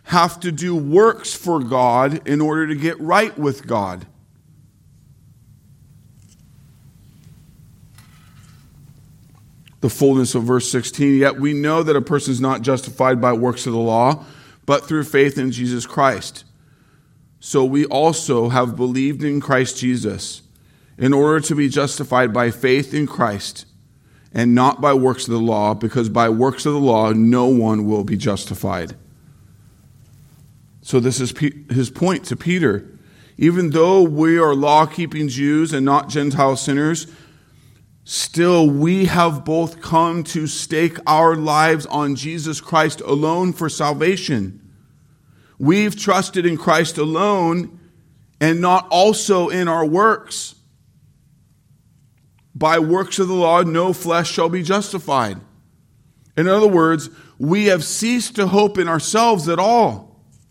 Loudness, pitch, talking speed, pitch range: -17 LUFS, 145 Hz, 140 wpm, 130-165 Hz